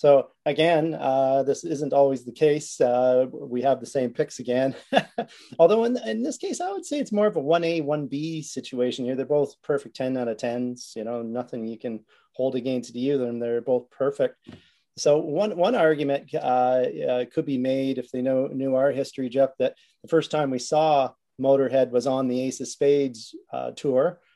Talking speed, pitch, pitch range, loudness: 200 wpm, 135 Hz, 125-155 Hz, -24 LUFS